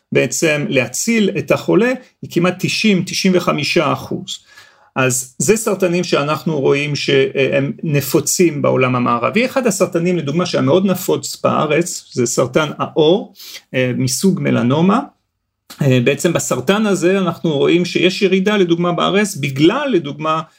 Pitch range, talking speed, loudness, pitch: 140-190 Hz, 115 wpm, -15 LUFS, 175 Hz